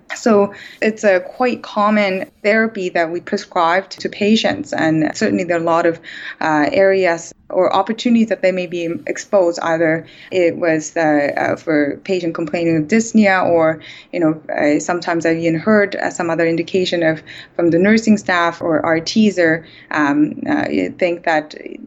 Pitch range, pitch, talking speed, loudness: 165-205 Hz, 175 Hz, 175 wpm, -16 LUFS